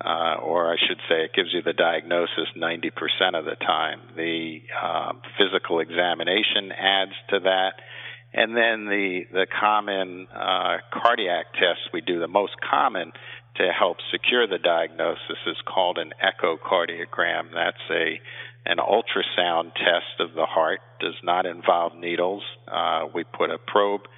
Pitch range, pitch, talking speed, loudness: 85-100 Hz, 95 Hz, 150 wpm, -24 LUFS